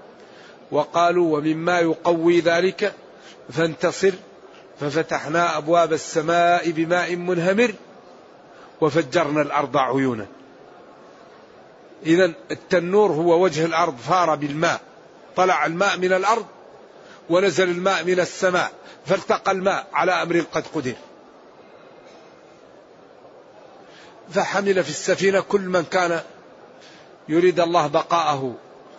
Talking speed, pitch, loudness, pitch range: 90 wpm, 170 Hz, -21 LUFS, 160-185 Hz